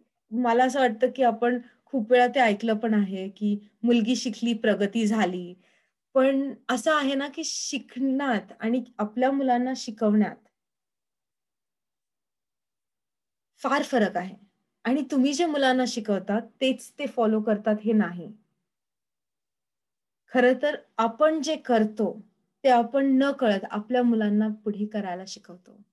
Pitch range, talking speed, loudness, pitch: 210-260 Hz, 125 wpm, -25 LUFS, 235 Hz